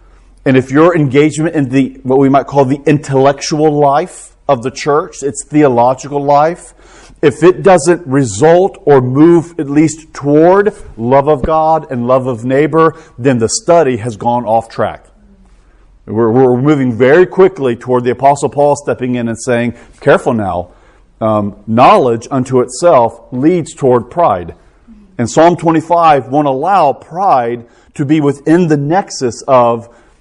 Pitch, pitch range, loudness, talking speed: 140 Hz, 125-155 Hz, -11 LUFS, 150 wpm